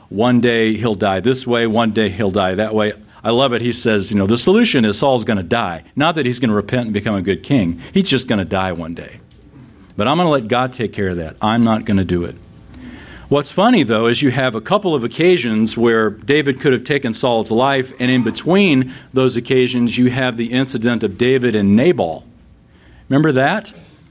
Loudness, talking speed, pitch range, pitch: -16 LUFS, 230 wpm, 105-130 Hz, 120 Hz